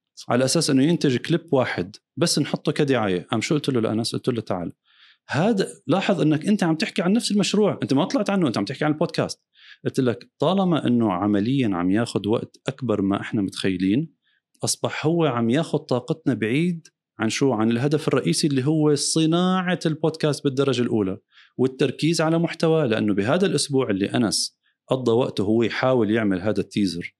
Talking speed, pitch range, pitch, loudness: 175 wpm, 115-160 Hz, 145 Hz, -22 LUFS